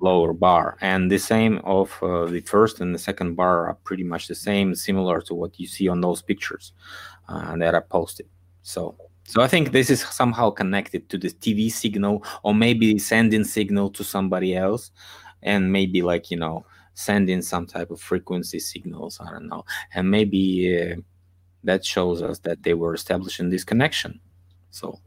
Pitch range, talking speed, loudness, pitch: 90-105 Hz, 180 wpm, -22 LUFS, 95 Hz